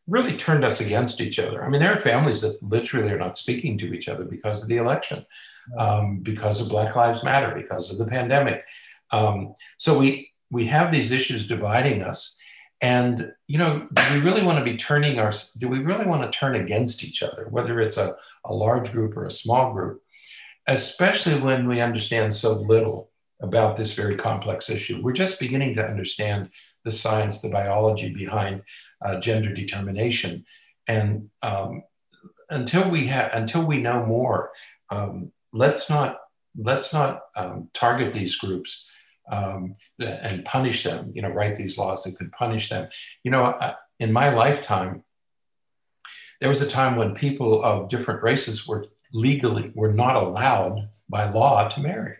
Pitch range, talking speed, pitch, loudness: 105-135 Hz, 170 wpm, 115 Hz, -23 LUFS